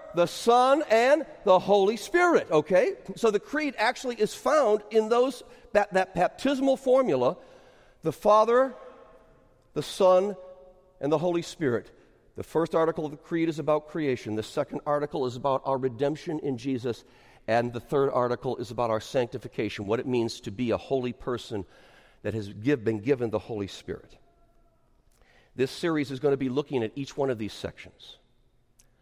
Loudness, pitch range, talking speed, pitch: -27 LUFS, 125-205 Hz, 170 wpm, 150 Hz